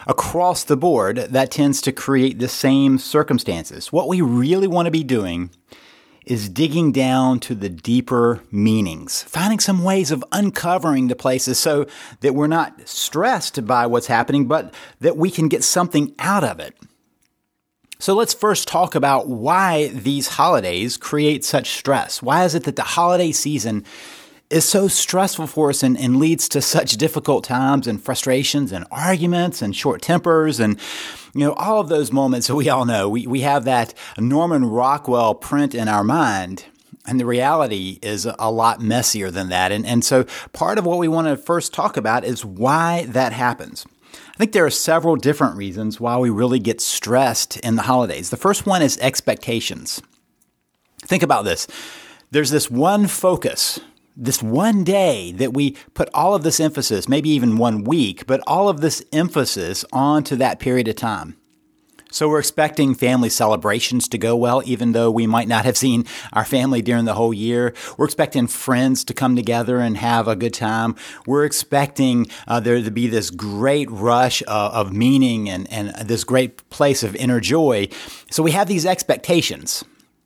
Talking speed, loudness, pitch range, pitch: 180 wpm, -18 LUFS, 115-155 Hz, 130 Hz